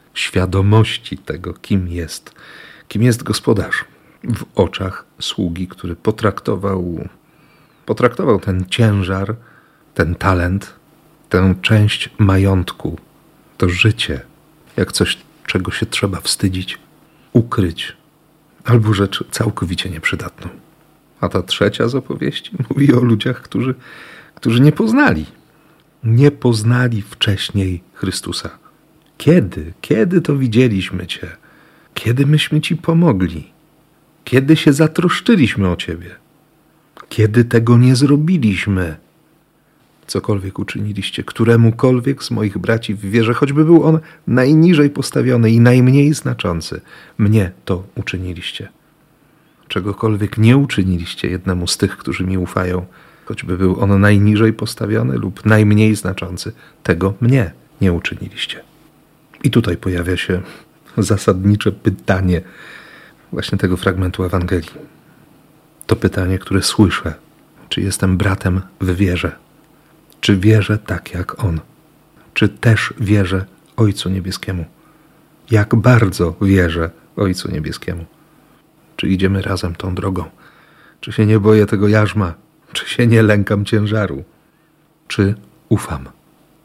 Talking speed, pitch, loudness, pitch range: 110 wpm, 105 Hz, -16 LUFS, 95-130 Hz